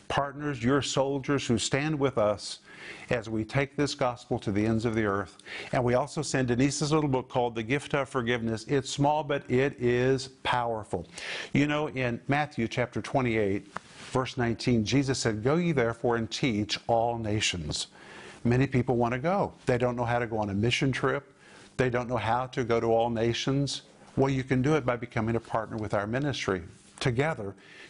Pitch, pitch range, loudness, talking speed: 125 Hz, 115-140 Hz, -28 LUFS, 195 wpm